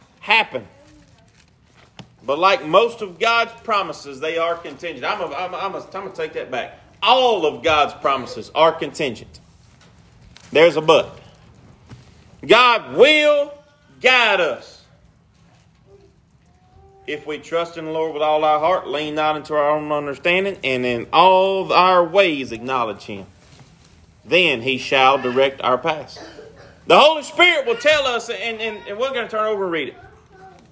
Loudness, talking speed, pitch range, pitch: -17 LUFS, 155 wpm, 145-225 Hz, 170 Hz